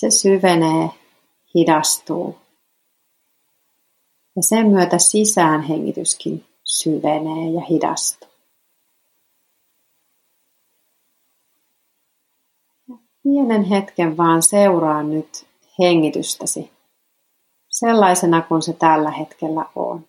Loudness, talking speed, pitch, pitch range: -17 LUFS, 70 wpm, 170 Hz, 160-200 Hz